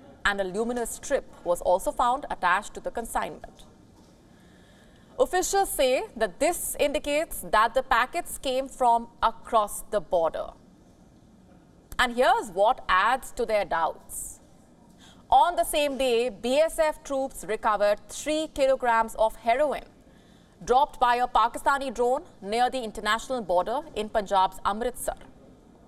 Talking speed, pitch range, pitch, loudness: 125 wpm, 215-285 Hz, 245 Hz, -26 LUFS